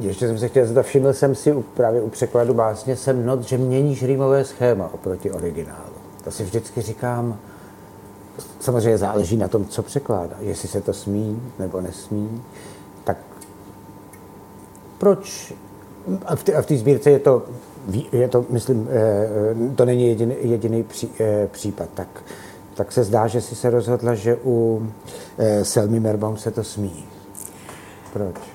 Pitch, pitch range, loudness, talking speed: 110 Hz, 100-125 Hz, -21 LUFS, 145 wpm